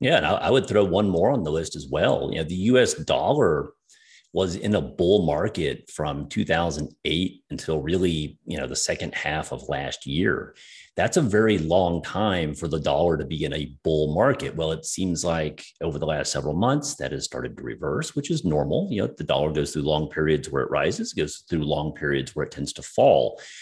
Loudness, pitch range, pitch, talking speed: -24 LUFS, 75-95 Hz, 80 Hz, 215 wpm